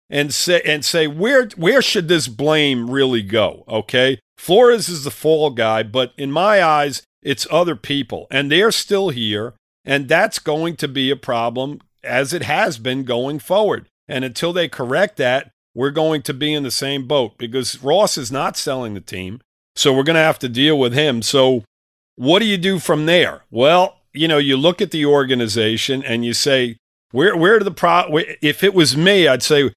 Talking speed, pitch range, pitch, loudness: 200 wpm, 125-160 Hz, 140 Hz, -16 LUFS